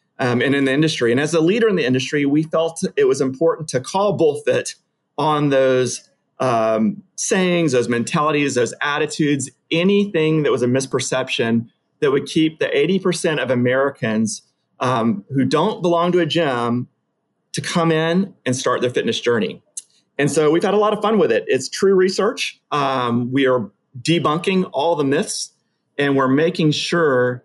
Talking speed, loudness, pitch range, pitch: 175 wpm, -18 LUFS, 130-180 Hz, 155 Hz